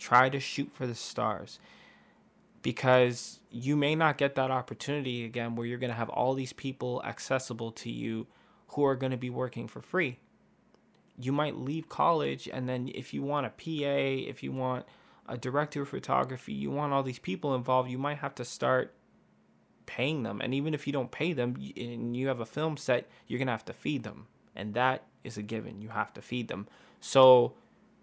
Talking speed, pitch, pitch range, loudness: 205 wpm, 130 Hz, 120-140 Hz, -31 LUFS